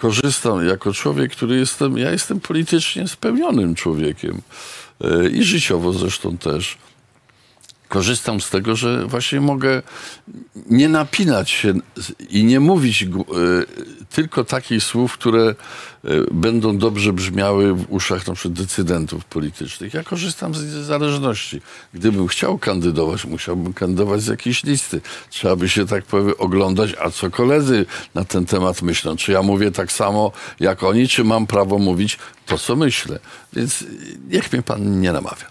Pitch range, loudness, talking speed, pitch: 90-125 Hz, -18 LUFS, 140 wpm, 100 Hz